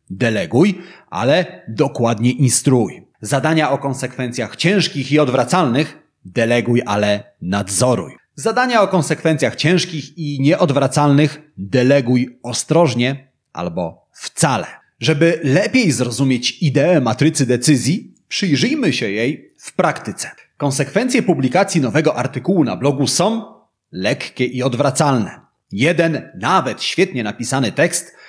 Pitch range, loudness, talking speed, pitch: 125-160 Hz, -17 LUFS, 105 wpm, 140 Hz